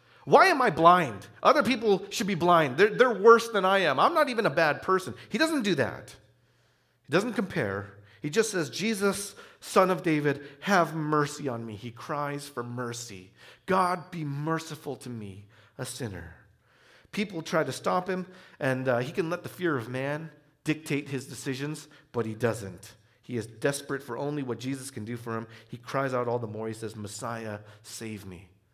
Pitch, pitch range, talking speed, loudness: 140 Hz, 115-175 Hz, 190 wpm, -27 LUFS